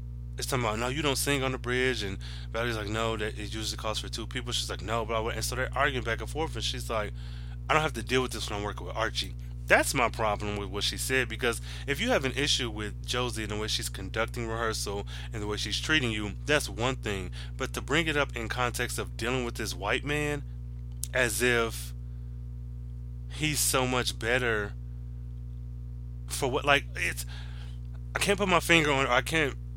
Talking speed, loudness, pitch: 220 wpm, -29 LUFS, 110 Hz